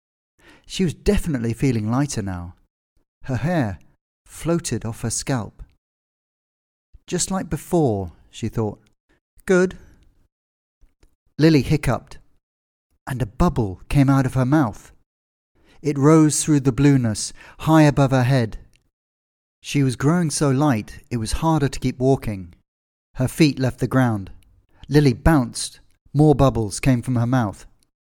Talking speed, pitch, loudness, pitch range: 130 wpm, 120 Hz, -20 LUFS, 90-145 Hz